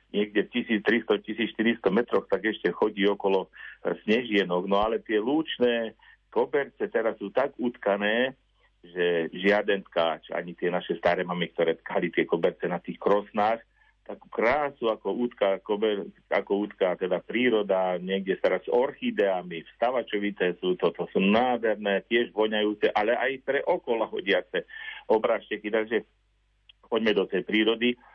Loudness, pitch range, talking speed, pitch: -27 LUFS, 95-120 Hz, 140 wpm, 105 Hz